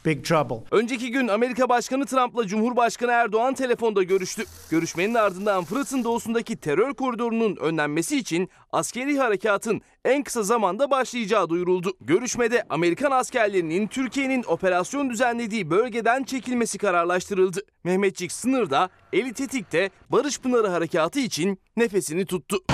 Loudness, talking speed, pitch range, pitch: -24 LUFS, 115 wpm, 185-250 Hz, 225 Hz